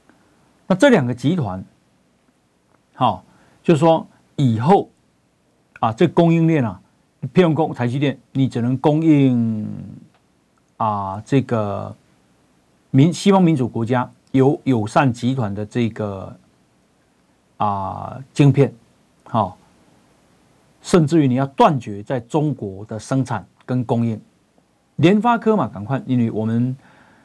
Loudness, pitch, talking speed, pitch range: -19 LUFS, 125 Hz, 170 characters per minute, 105-150 Hz